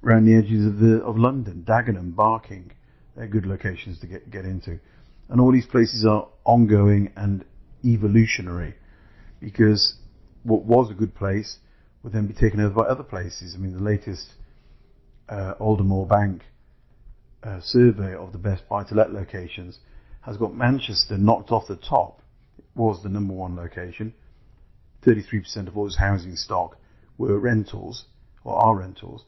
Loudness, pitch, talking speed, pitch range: -22 LUFS, 105 Hz, 155 wpm, 95-110 Hz